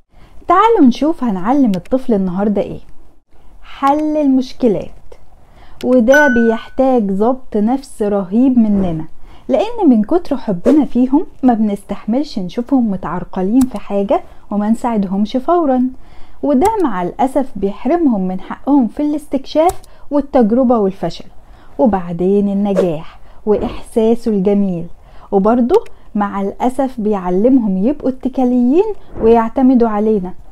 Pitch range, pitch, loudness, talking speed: 205-270 Hz, 240 Hz, -15 LUFS, 100 wpm